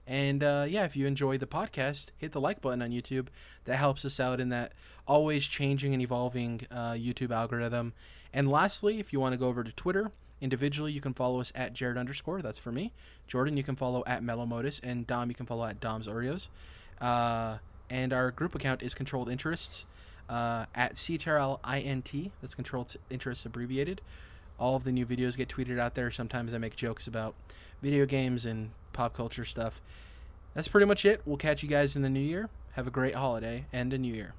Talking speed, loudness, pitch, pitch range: 215 wpm, -32 LUFS, 125 Hz, 120-140 Hz